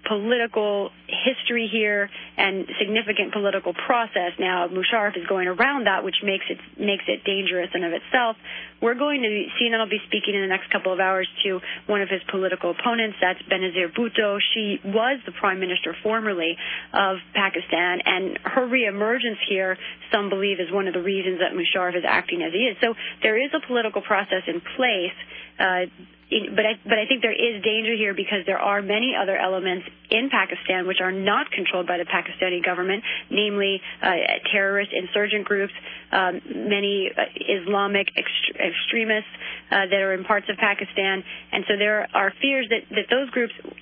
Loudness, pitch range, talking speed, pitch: -23 LUFS, 185-220 Hz, 180 wpm, 200 Hz